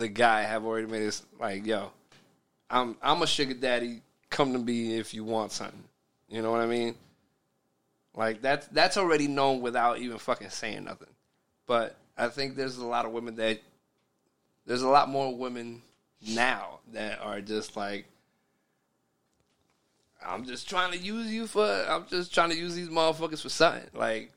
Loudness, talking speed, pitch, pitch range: -29 LUFS, 175 wpm, 120 Hz, 110-145 Hz